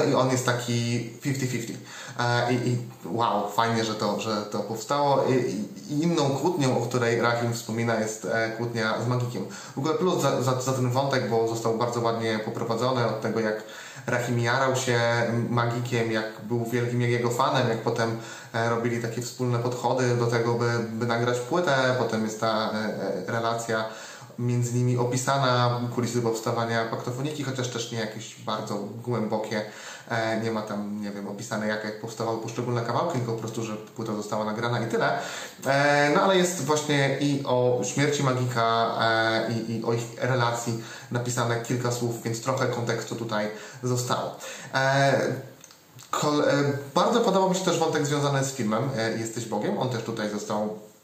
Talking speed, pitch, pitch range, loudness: 160 wpm, 120 Hz, 115-125 Hz, -26 LUFS